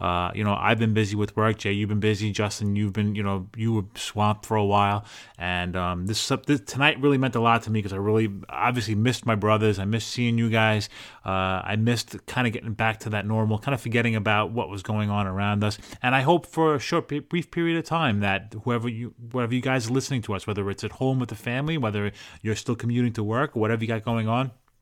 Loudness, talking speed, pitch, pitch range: -25 LUFS, 255 wpm, 110 Hz, 105-120 Hz